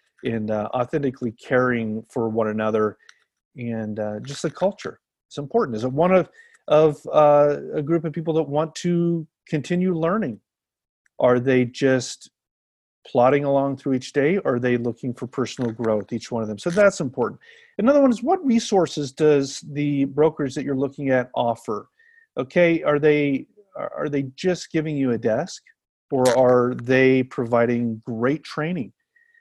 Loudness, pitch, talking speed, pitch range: -22 LUFS, 140 Hz, 165 wpm, 120-165 Hz